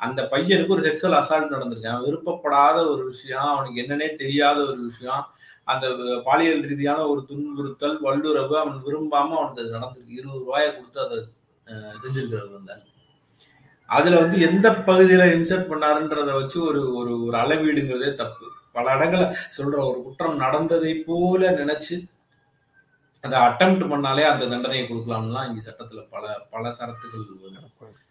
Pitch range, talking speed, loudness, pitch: 125-155 Hz, 130 wpm, -21 LUFS, 145 Hz